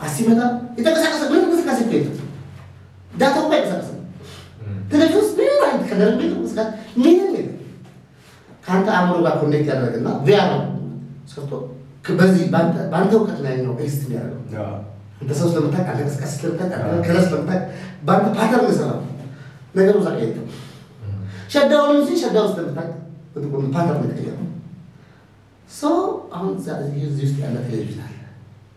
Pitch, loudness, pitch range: 160 Hz, -19 LUFS, 135-215 Hz